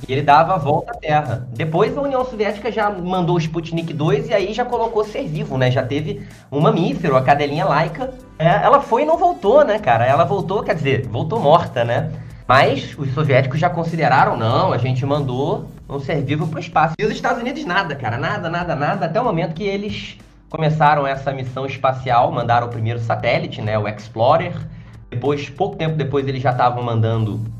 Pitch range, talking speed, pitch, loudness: 130-180 Hz, 205 wpm, 150 Hz, -18 LUFS